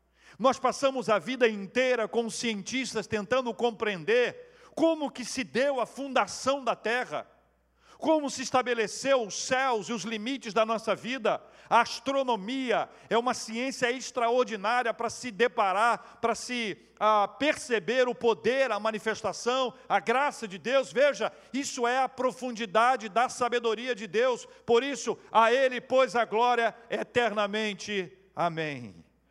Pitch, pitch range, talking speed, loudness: 235 Hz, 220-260 Hz, 140 wpm, -28 LUFS